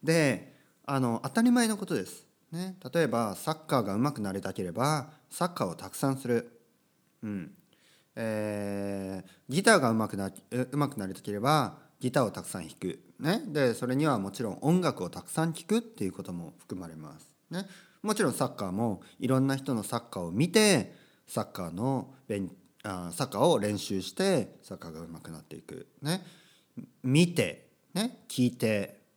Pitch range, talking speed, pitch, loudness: 100-165 Hz, 335 characters per minute, 130 Hz, -30 LUFS